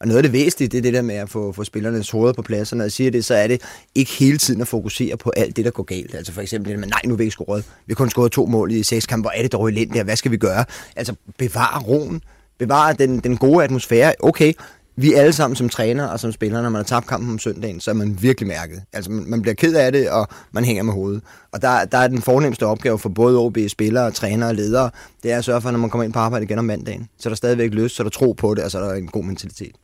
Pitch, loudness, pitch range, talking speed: 115 Hz, -19 LUFS, 105-125 Hz, 300 wpm